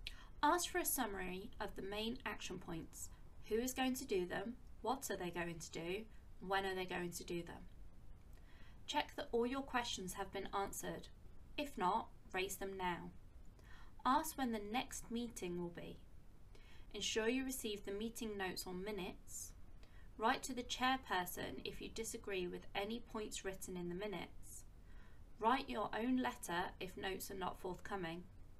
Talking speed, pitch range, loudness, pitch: 165 wpm, 175-225 Hz, -43 LUFS, 195 Hz